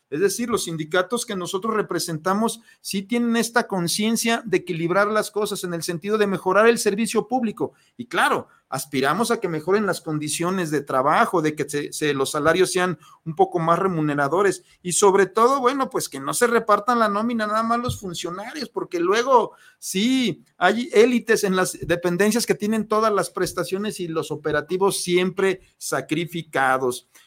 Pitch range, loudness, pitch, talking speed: 170-225 Hz, -22 LUFS, 195 Hz, 170 wpm